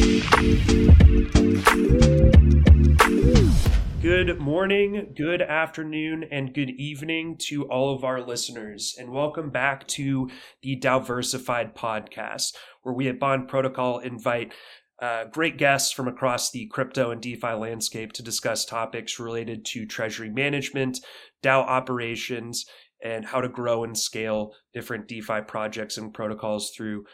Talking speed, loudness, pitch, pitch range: 125 wpm, -23 LUFS, 125 Hz, 110-135 Hz